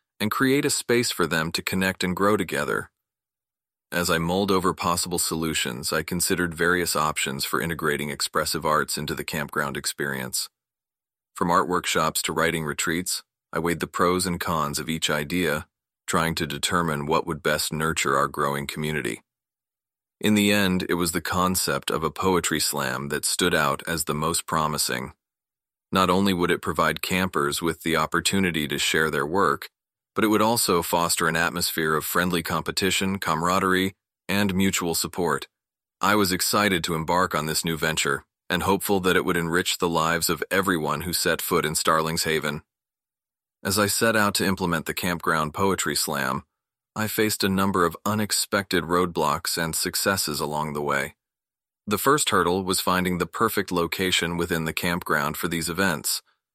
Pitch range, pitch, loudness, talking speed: 80-95 Hz, 85 Hz, -24 LUFS, 170 wpm